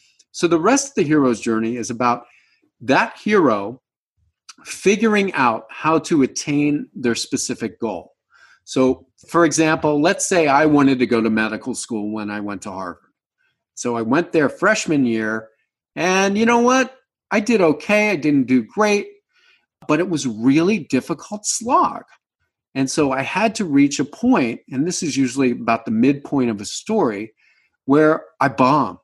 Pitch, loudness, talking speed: 155 Hz, -18 LUFS, 165 wpm